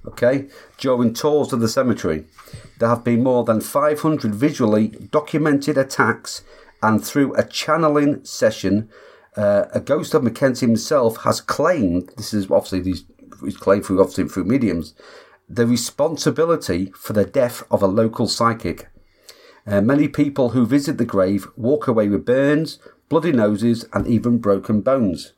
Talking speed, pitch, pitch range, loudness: 150 wpm, 120 Hz, 105-140 Hz, -19 LUFS